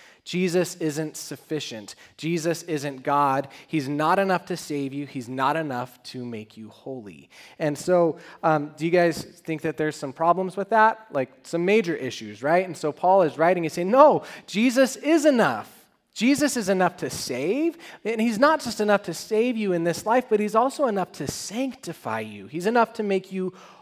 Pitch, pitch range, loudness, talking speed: 170 Hz, 145-210 Hz, -24 LUFS, 190 wpm